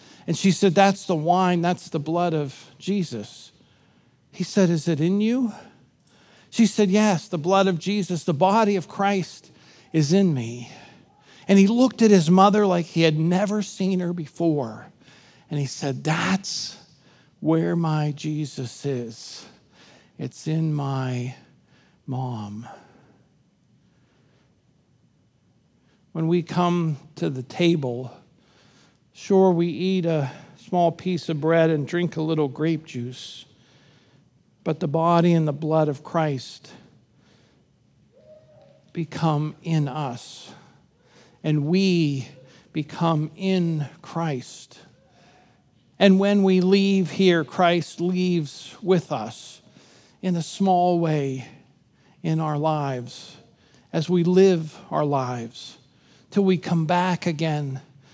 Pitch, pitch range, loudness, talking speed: 165 Hz, 145-185 Hz, -23 LUFS, 120 wpm